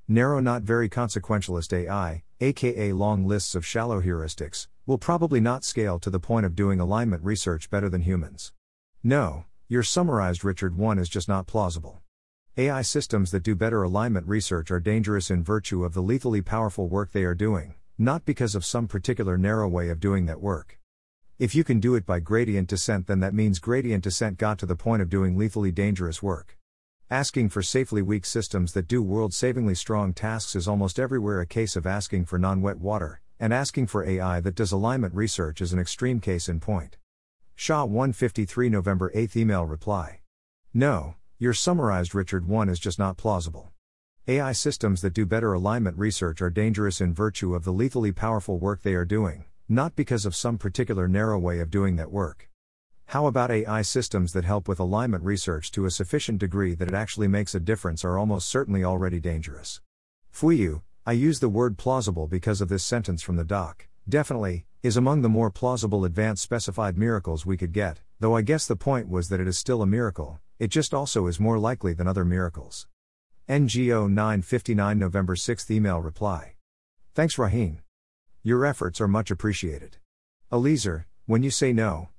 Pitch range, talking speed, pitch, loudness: 90-115 Hz, 185 wpm, 100 Hz, -26 LUFS